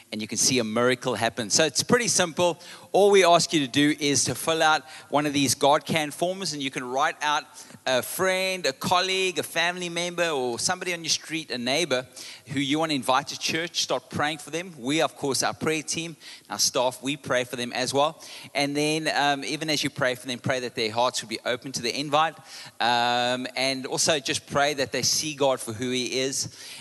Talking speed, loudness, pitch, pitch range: 225 wpm, -24 LUFS, 145 Hz, 130-165 Hz